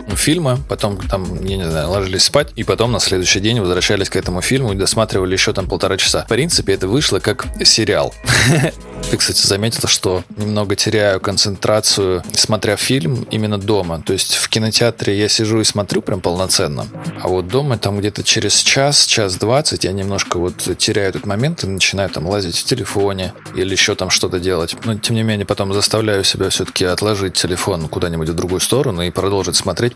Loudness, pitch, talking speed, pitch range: -15 LUFS, 100 Hz, 185 wpm, 95-110 Hz